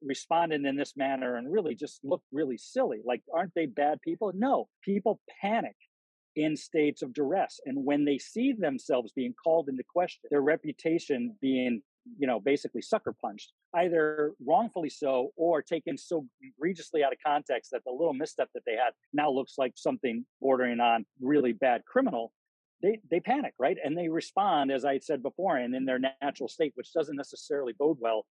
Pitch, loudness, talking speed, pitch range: 160 Hz, -30 LUFS, 180 wpm, 135-205 Hz